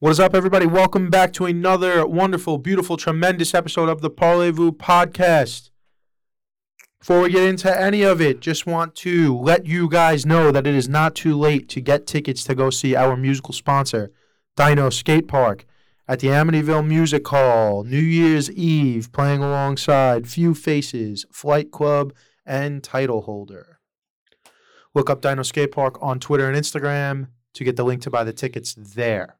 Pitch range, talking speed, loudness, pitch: 130-170 Hz, 165 wpm, -19 LUFS, 145 Hz